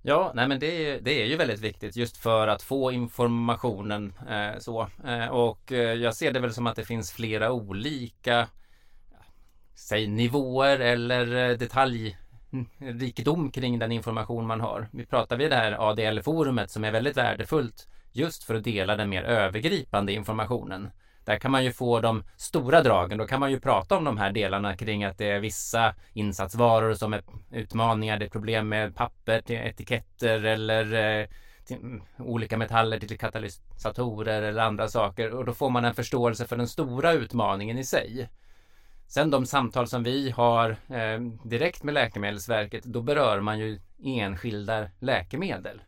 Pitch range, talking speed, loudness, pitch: 105-125 Hz, 160 wpm, -27 LUFS, 115 Hz